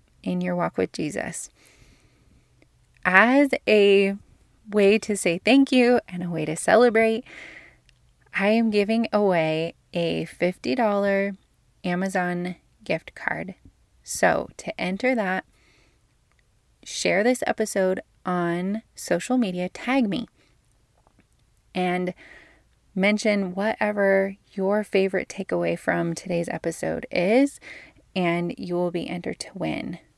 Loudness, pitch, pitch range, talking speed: -23 LUFS, 195 Hz, 175-215 Hz, 110 wpm